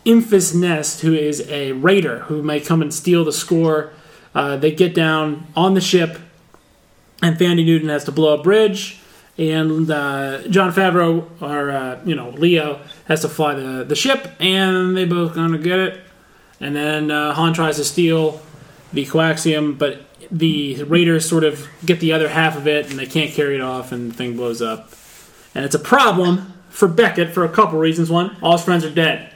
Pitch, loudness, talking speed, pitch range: 160 Hz, -17 LUFS, 195 wpm, 150-175 Hz